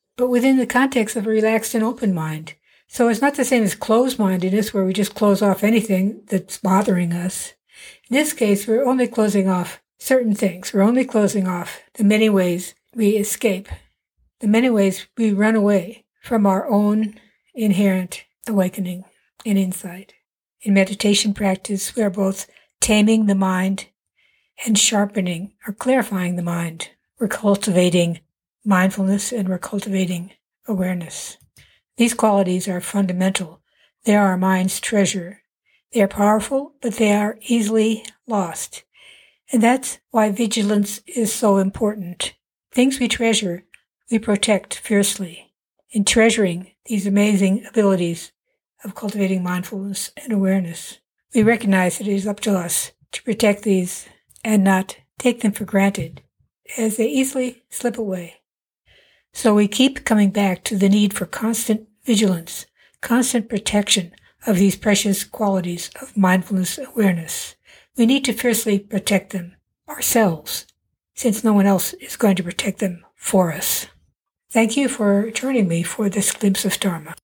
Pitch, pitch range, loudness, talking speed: 205 Hz, 190-225 Hz, -19 LUFS, 150 wpm